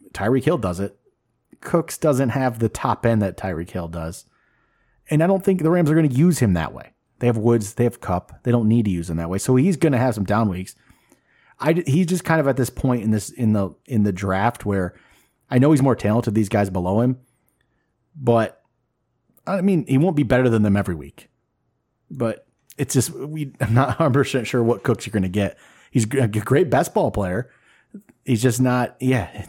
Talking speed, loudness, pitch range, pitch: 225 wpm, -20 LUFS, 105-135 Hz, 120 Hz